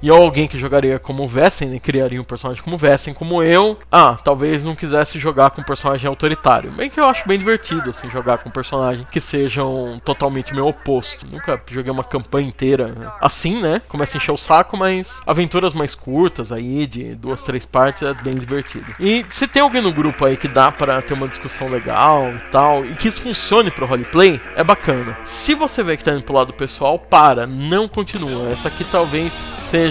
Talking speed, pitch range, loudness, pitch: 210 wpm, 130-170 Hz, -16 LUFS, 145 Hz